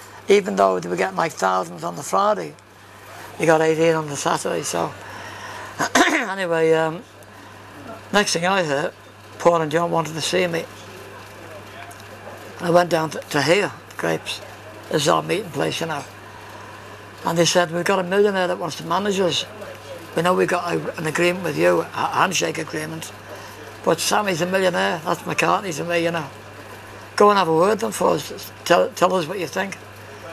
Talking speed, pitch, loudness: 190 wpm, 160 Hz, -20 LUFS